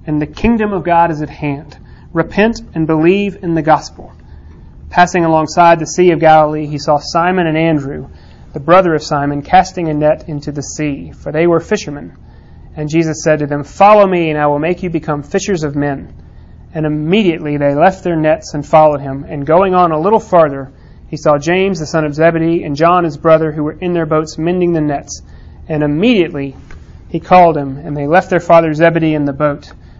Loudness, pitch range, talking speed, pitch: -12 LUFS, 145-170 Hz, 205 wpm, 155 Hz